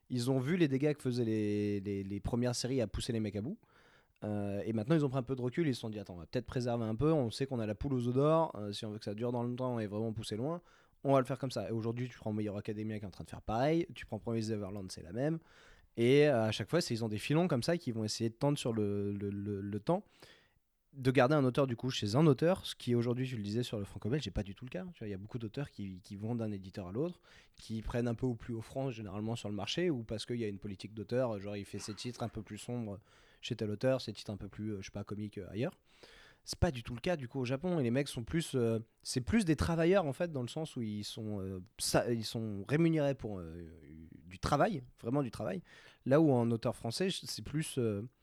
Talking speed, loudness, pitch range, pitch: 295 wpm, -36 LUFS, 105-135 Hz, 115 Hz